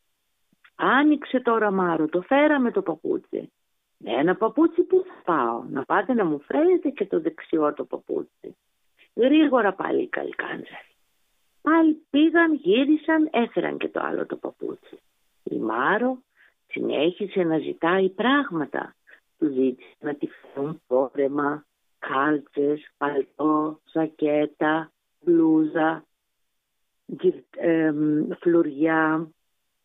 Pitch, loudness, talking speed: 190 Hz, -23 LUFS, 110 wpm